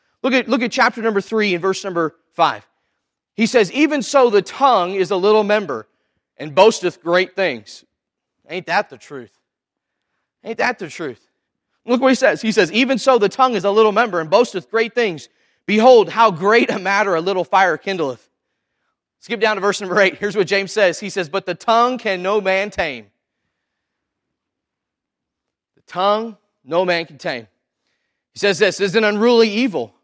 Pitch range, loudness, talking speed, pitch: 180-225 Hz, -17 LUFS, 185 wpm, 200 Hz